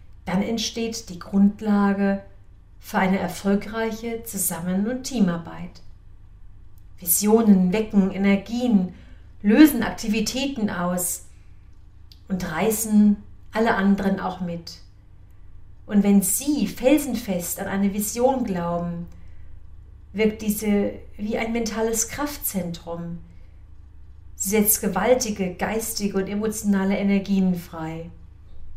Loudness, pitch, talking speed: -22 LUFS, 195 Hz, 90 wpm